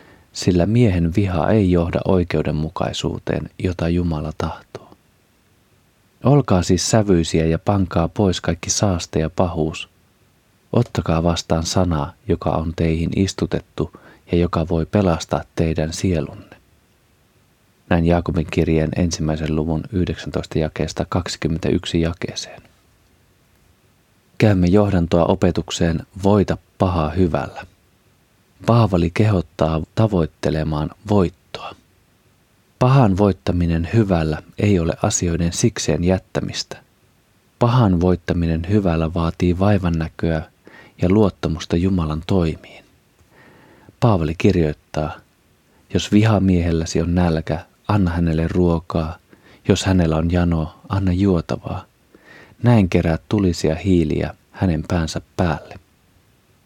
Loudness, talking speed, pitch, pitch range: -19 LUFS, 95 wpm, 90 Hz, 80-95 Hz